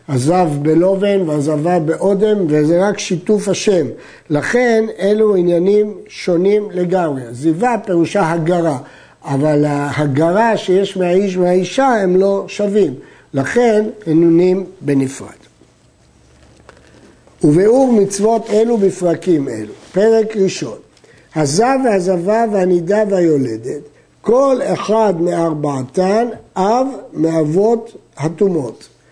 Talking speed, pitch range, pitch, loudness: 90 wpm, 160-210 Hz, 185 Hz, -15 LUFS